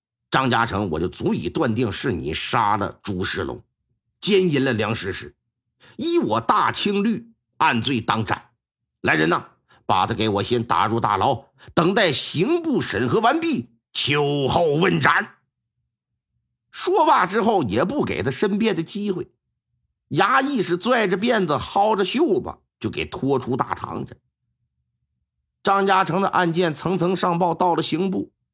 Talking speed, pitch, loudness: 210 characters per minute, 165 Hz, -21 LUFS